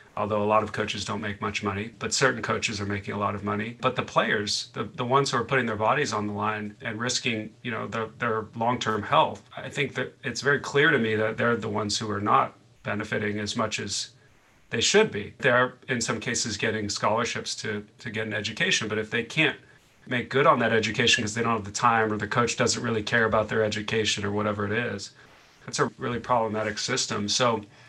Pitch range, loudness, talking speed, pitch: 105-120 Hz, -26 LUFS, 230 wpm, 110 Hz